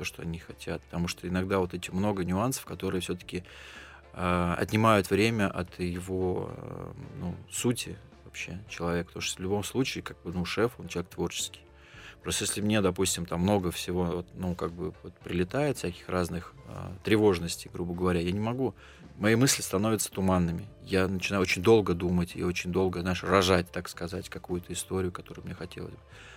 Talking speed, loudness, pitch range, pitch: 180 wpm, -30 LUFS, 90-105 Hz, 90 Hz